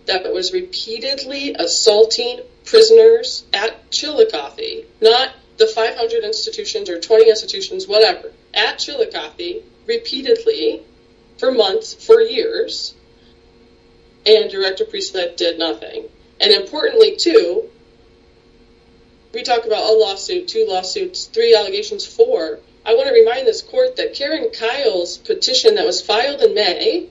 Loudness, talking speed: -16 LUFS, 125 wpm